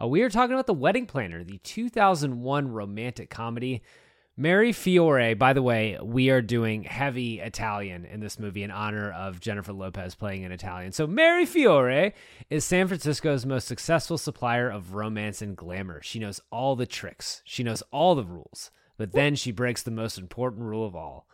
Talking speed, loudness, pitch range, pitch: 185 wpm, -26 LUFS, 105-145 Hz, 120 Hz